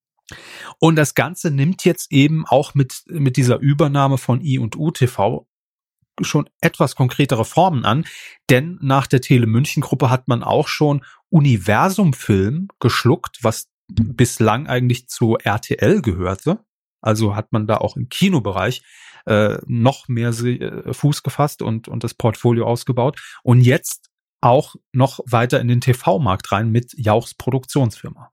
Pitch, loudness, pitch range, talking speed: 130 Hz, -18 LUFS, 120-150 Hz, 140 wpm